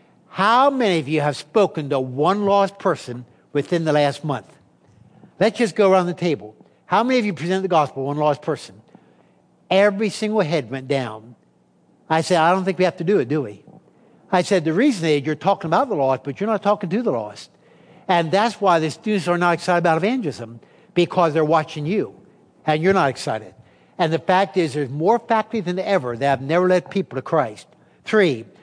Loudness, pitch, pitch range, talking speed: -20 LUFS, 175 Hz, 145-195 Hz, 210 wpm